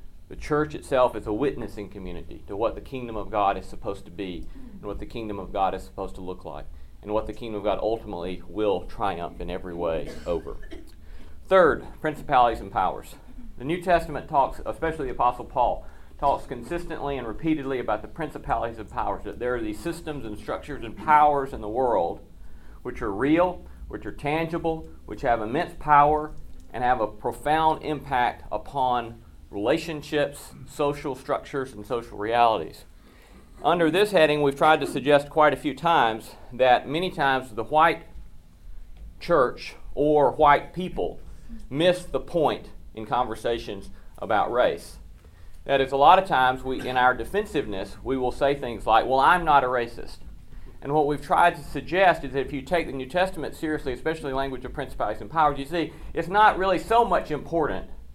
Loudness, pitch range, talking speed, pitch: -25 LUFS, 105-155 Hz, 175 wpm, 135 Hz